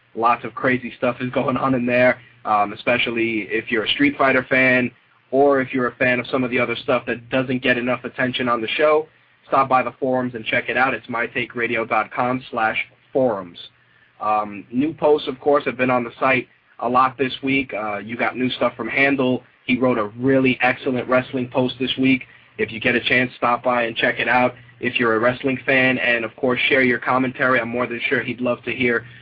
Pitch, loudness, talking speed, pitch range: 125 Hz, -20 LUFS, 220 wpm, 120-130 Hz